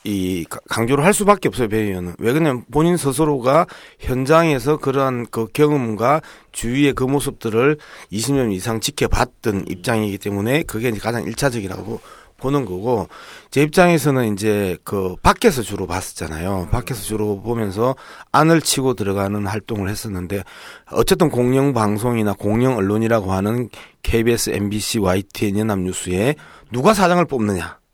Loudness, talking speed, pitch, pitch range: -19 LUFS, 325 characters per minute, 115 Hz, 100-140 Hz